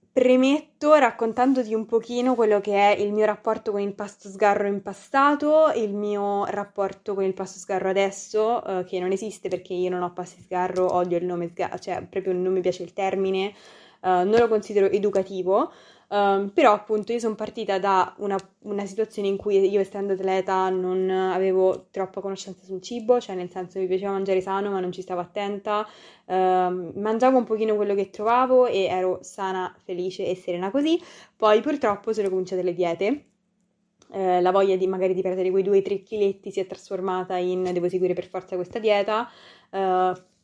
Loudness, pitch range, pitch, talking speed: -24 LUFS, 185-210 Hz, 195 Hz, 185 wpm